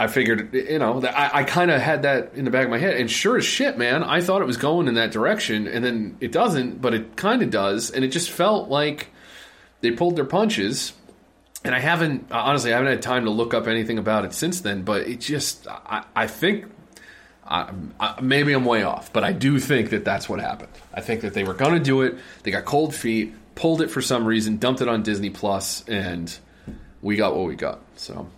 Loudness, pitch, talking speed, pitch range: -22 LUFS, 125 Hz, 245 wpm, 110-150 Hz